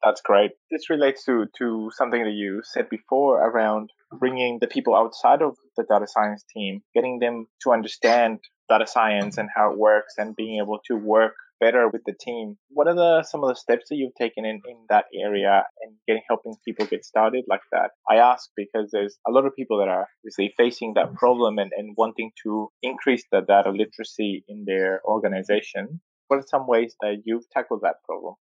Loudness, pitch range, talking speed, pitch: -23 LUFS, 105-125 Hz, 200 wpm, 110 Hz